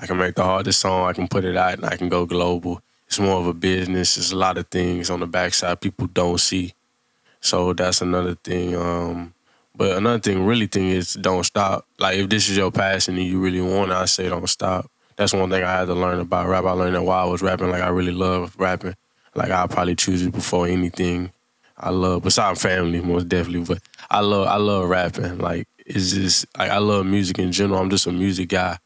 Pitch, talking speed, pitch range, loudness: 90 Hz, 240 wpm, 90-95 Hz, -20 LUFS